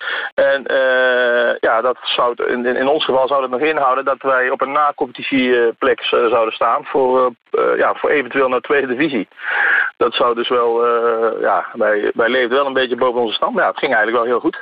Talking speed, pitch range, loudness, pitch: 220 wpm, 120-145 Hz, -16 LUFS, 130 Hz